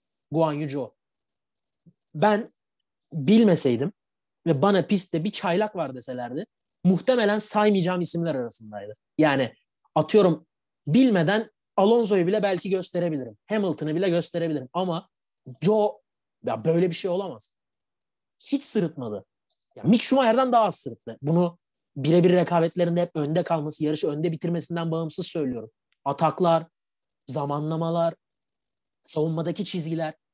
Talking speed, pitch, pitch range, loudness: 110 wpm, 170 Hz, 155-190 Hz, -24 LUFS